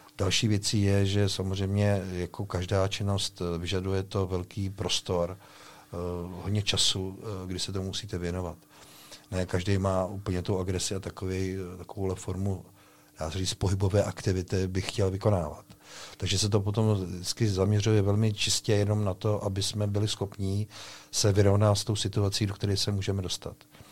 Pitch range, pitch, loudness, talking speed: 95-105 Hz, 100 Hz, -29 LUFS, 155 wpm